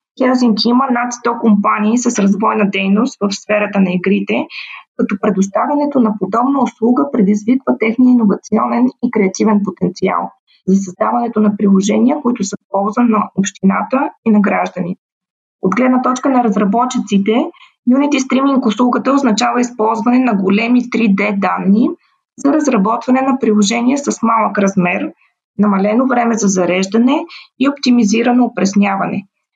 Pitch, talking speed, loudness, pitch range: 225 Hz, 130 wpm, -14 LUFS, 205-250 Hz